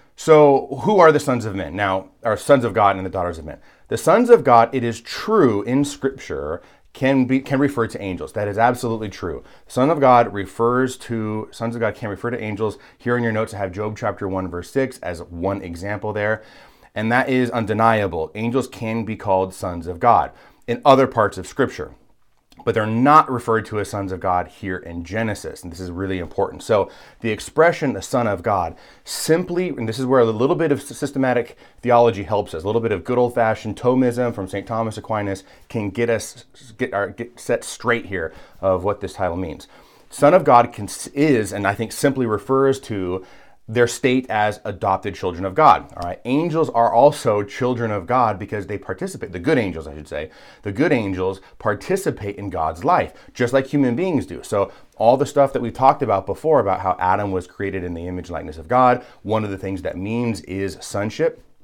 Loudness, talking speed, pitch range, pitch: -20 LUFS, 210 wpm, 100-130 Hz, 115 Hz